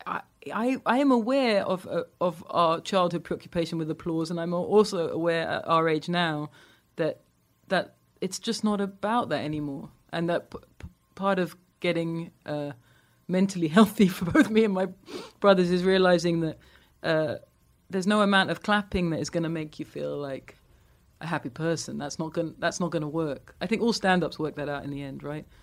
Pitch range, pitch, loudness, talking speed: 155-190 Hz, 170 Hz, -27 LUFS, 200 wpm